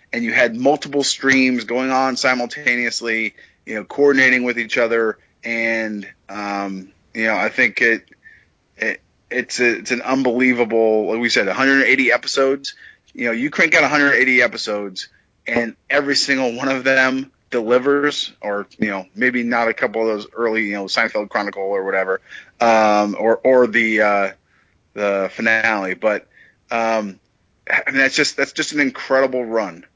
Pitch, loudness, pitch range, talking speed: 120 Hz, -17 LUFS, 110-130 Hz, 160 wpm